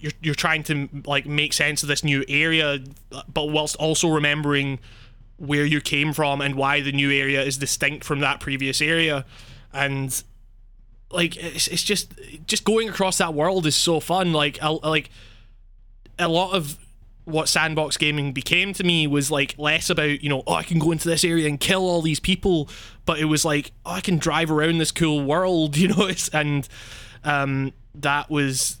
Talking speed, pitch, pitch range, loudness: 190 wpm, 150 Hz, 140-165 Hz, -21 LUFS